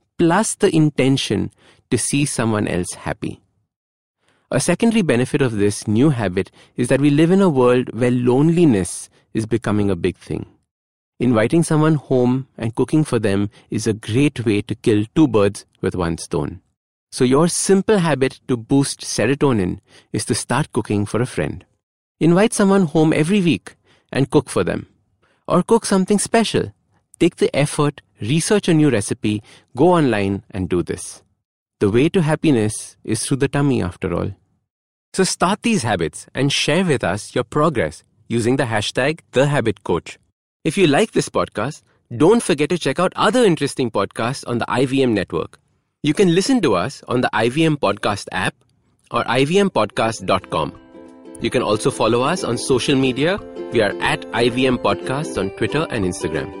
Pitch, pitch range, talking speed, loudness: 130 Hz, 105-155 Hz, 165 wpm, -18 LUFS